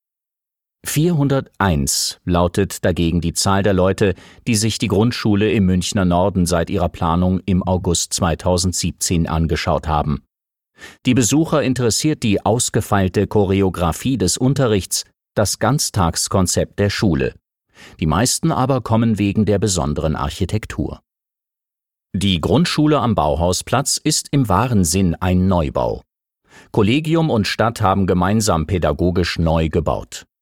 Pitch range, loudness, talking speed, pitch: 85-115 Hz, -18 LUFS, 120 wpm, 95 Hz